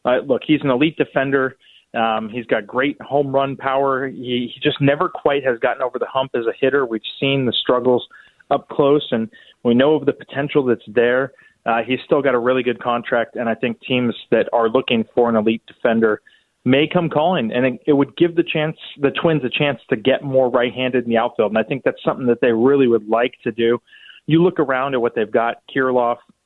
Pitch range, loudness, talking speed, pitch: 120-140 Hz, -19 LUFS, 225 wpm, 130 Hz